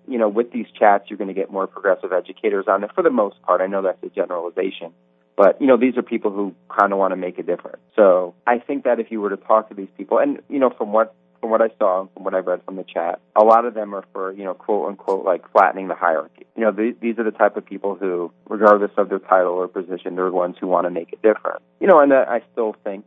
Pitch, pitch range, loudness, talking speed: 100 Hz, 90-110 Hz, -19 LUFS, 290 wpm